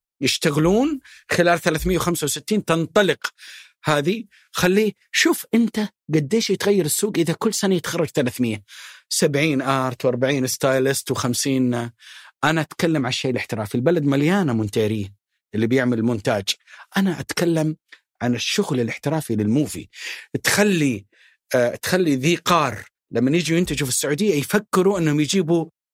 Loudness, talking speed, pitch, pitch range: -21 LUFS, 120 wpm, 155 Hz, 130-185 Hz